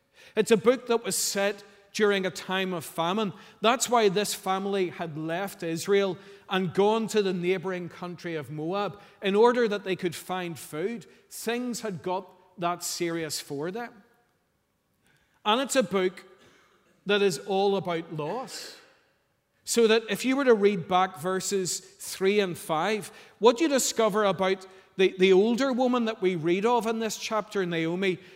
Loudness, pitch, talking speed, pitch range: -27 LUFS, 195 Hz, 165 wpm, 185-220 Hz